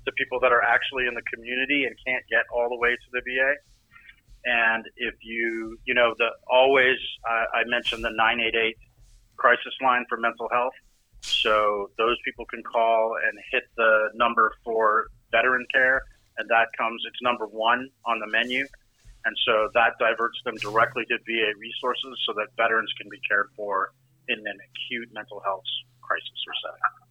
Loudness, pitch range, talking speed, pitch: -24 LUFS, 115-125 Hz, 180 wpm, 115 Hz